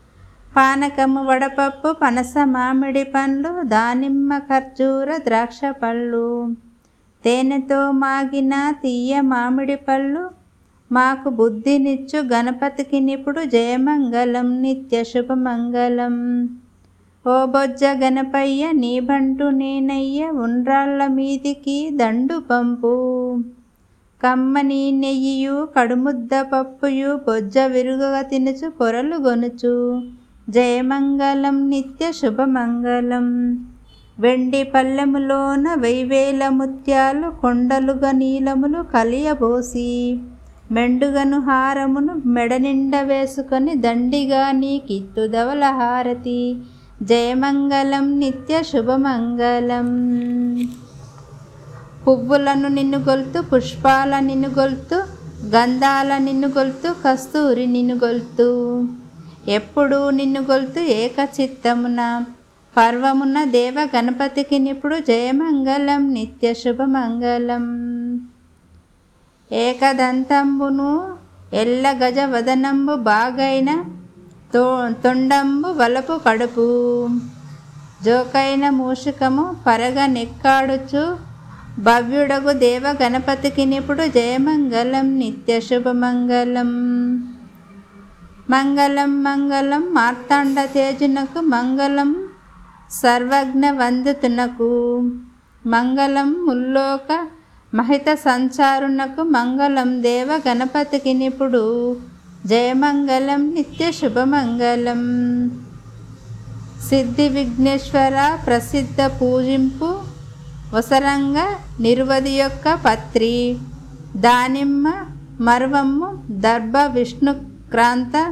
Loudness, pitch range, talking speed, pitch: -18 LUFS, 245-275 Hz, 70 wpm, 265 Hz